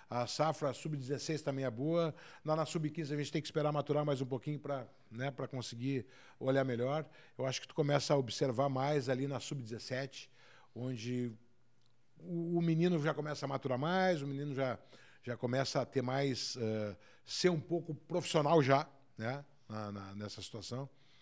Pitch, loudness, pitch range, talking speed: 135 Hz, -37 LUFS, 125-150 Hz, 185 wpm